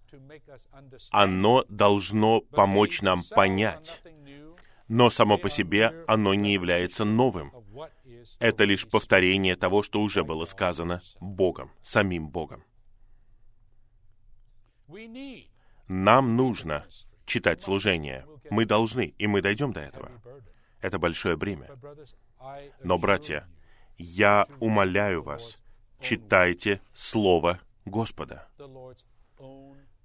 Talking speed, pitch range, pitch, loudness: 90 wpm, 95-120 Hz, 110 Hz, -24 LUFS